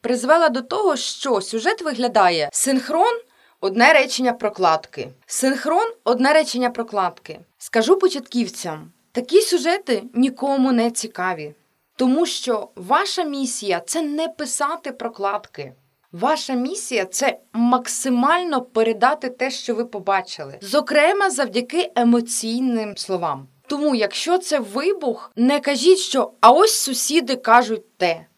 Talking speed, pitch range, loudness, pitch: 115 wpm, 210-300 Hz, -19 LUFS, 250 Hz